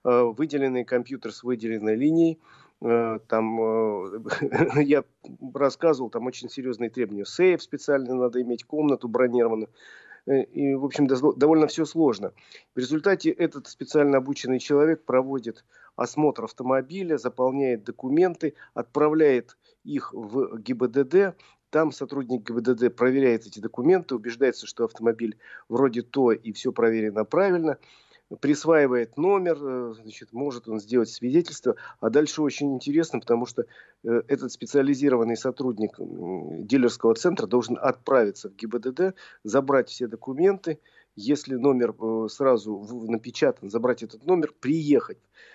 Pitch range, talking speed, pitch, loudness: 120-150 Hz, 115 wpm, 130 Hz, -25 LUFS